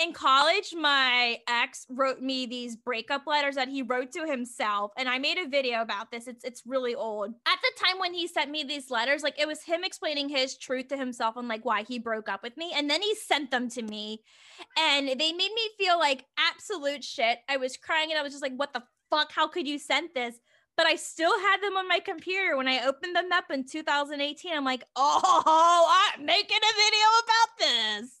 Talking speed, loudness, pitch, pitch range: 225 wpm, -26 LUFS, 285 Hz, 255-335 Hz